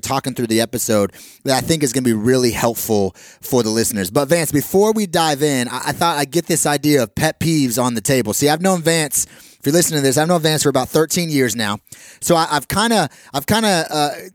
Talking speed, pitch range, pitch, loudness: 250 wpm, 125-165 Hz, 145 Hz, -17 LUFS